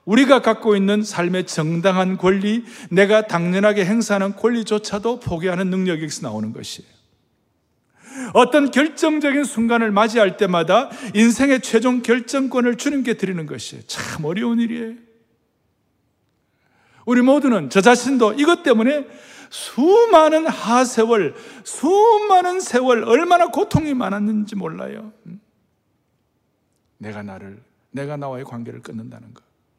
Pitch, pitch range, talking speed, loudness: 225 Hz, 185-260 Hz, 280 characters per minute, -17 LUFS